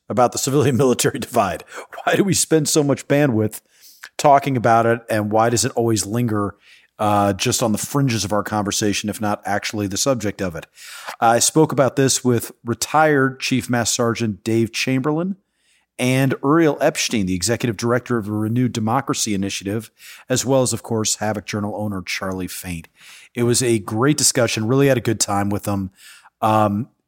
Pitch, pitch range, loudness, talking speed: 115 Hz, 105-130 Hz, -19 LUFS, 180 wpm